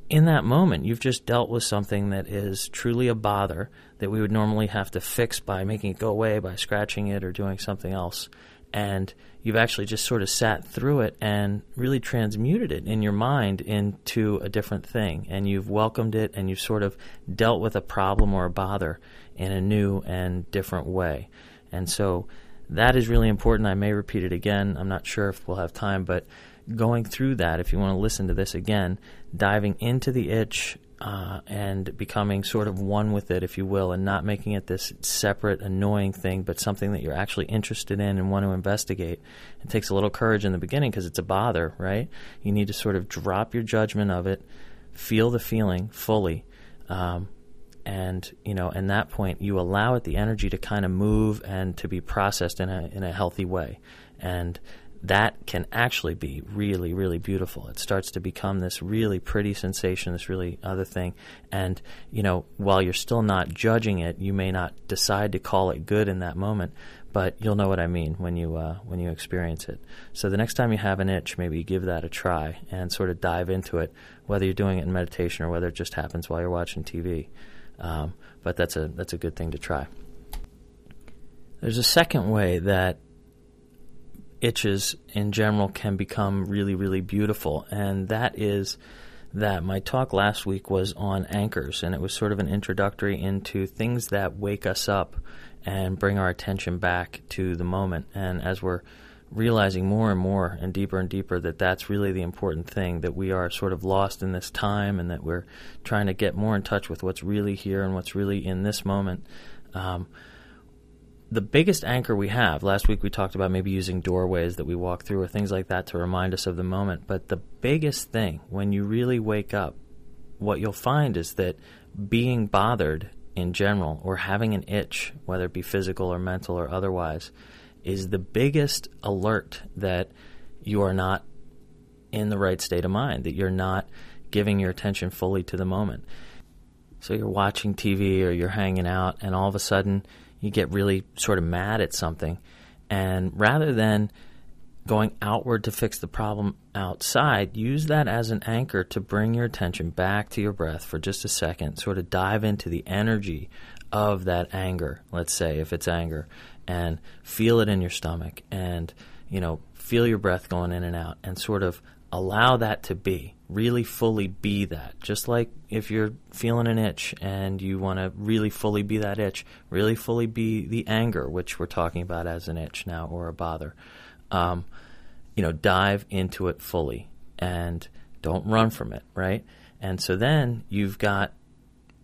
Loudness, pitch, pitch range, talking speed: -26 LUFS, 95 Hz, 90-105 Hz, 195 wpm